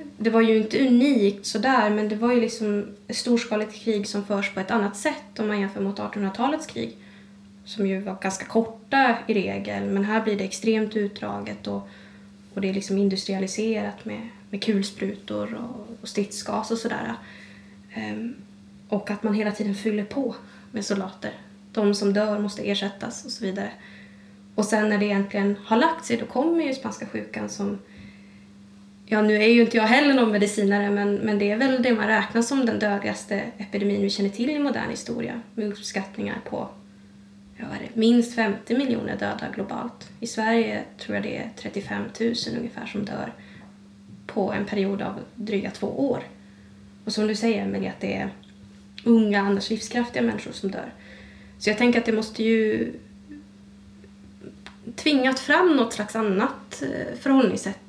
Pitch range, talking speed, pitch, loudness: 195-225 Hz, 170 wpm, 205 Hz, -24 LUFS